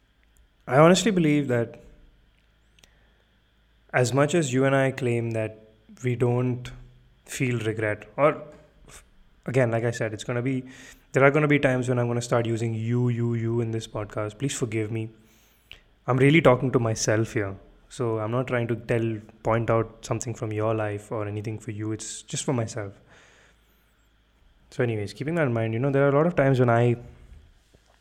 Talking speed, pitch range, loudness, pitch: 190 wpm, 110-130 Hz, -25 LUFS, 120 Hz